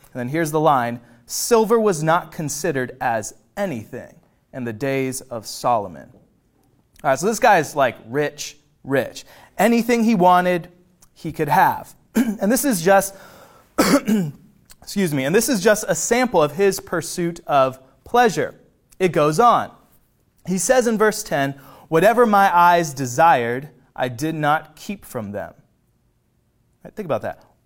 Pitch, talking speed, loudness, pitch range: 170 Hz, 150 wpm, -19 LUFS, 140-210 Hz